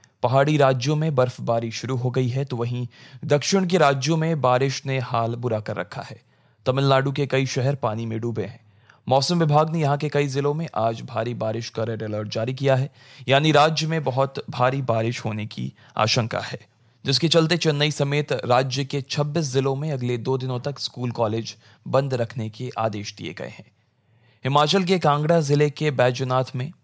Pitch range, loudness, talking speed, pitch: 115-145 Hz, -22 LUFS, 190 wpm, 130 Hz